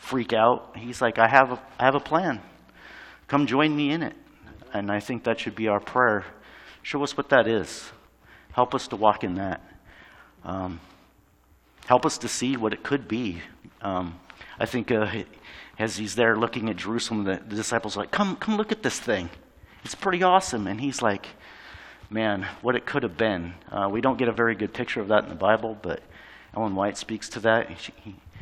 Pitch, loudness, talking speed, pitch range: 110 Hz, -25 LUFS, 205 wpm, 100-125 Hz